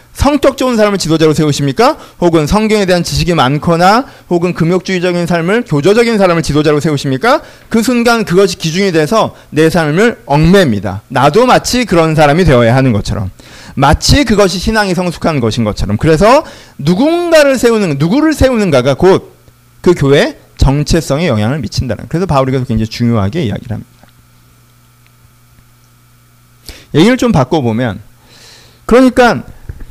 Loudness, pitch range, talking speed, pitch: -10 LUFS, 120-200 Hz, 350 characters per minute, 160 Hz